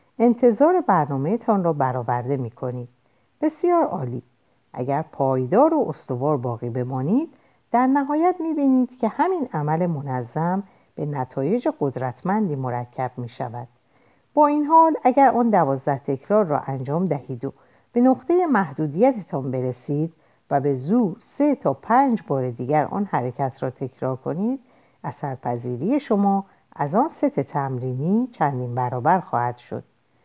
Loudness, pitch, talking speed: -22 LUFS, 150 Hz, 135 wpm